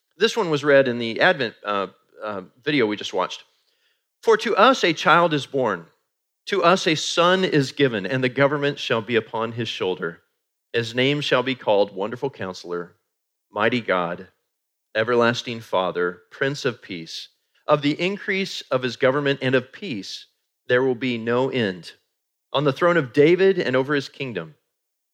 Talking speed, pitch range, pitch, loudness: 170 wpm, 115-150 Hz, 130 Hz, -21 LUFS